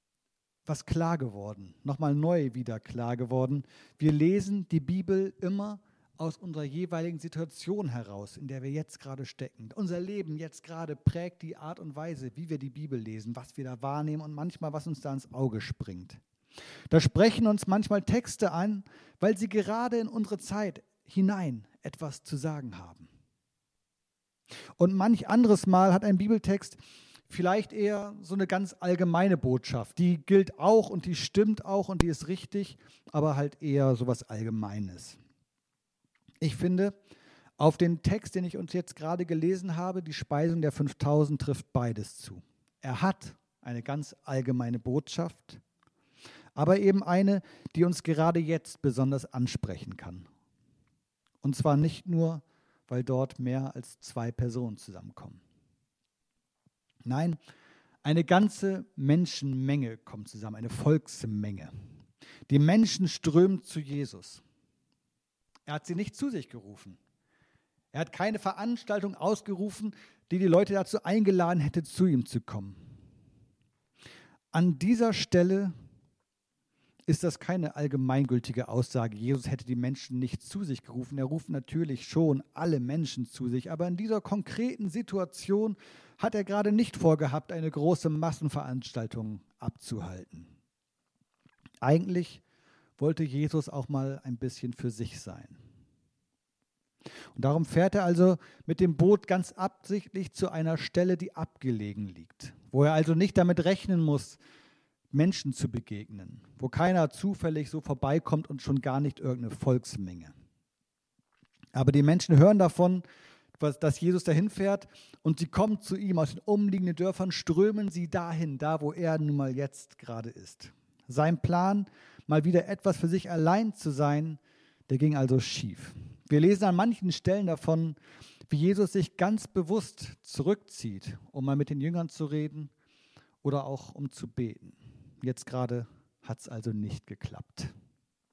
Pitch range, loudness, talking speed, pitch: 130-180 Hz, -29 LUFS, 145 wpm, 155 Hz